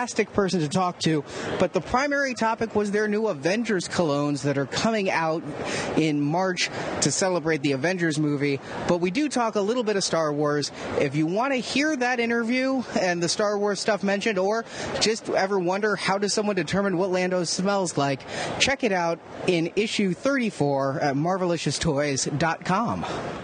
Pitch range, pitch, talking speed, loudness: 160-215 Hz, 185 Hz, 170 wpm, -24 LUFS